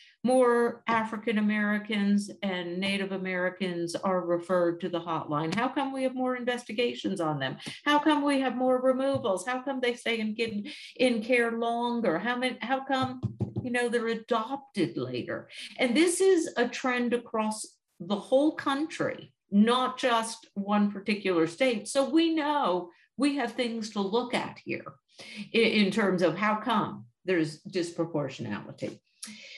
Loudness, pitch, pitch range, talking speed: -28 LUFS, 230 Hz, 190-255 Hz, 150 wpm